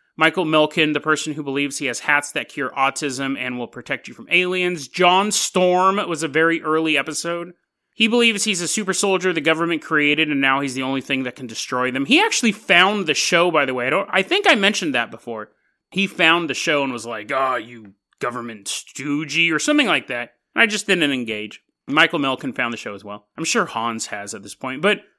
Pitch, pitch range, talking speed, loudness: 155 Hz, 135-185 Hz, 230 wpm, -19 LUFS